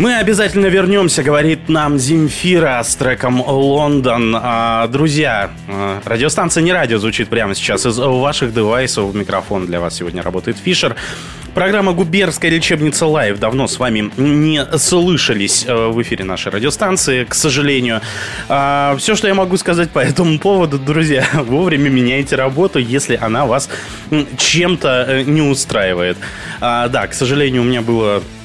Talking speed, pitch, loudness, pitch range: 135 wpm, 140 Hz, -14 LUFS, 115-160 Hz